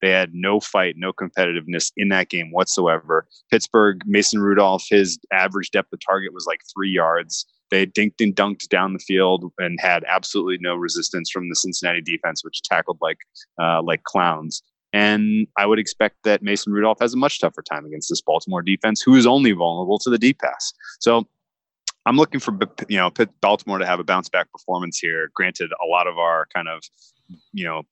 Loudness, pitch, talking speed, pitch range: -20 LUFS, 95 Hz, 195 wpm, 85-105 Hz